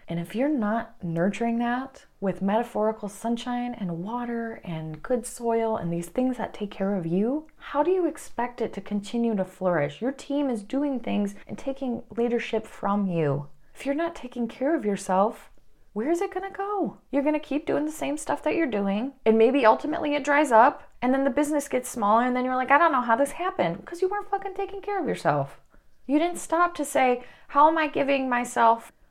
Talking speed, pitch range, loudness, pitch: 215 wpm, 210-290 Hz, -26 LUFS, 245 Hz